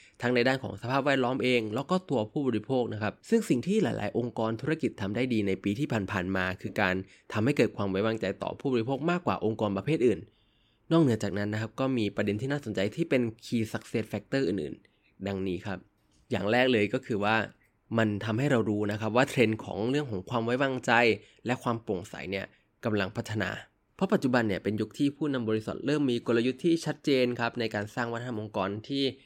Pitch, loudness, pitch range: 115 Hz, -29 LUFS, 105-130 Hz